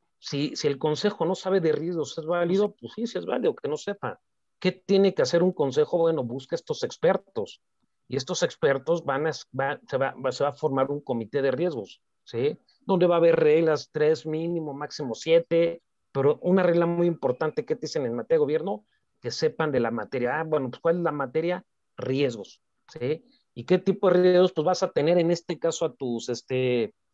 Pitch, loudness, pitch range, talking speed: 170 Hz, -26 LUFS, 150-190 Hz, 210 wpm